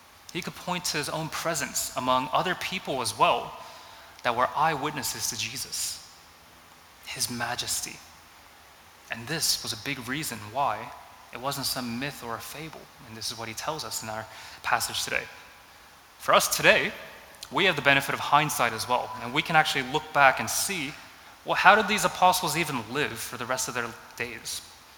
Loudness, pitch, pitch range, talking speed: -26 LUFS, 120 Hz, 110-140 Hz, 185 wpm